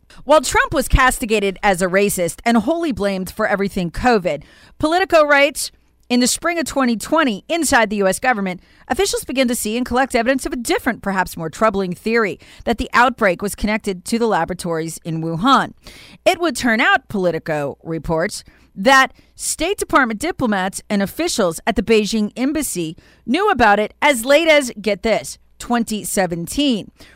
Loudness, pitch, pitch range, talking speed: -17 LUFS, 230 Hz, 195-280 Hz, 160 wpm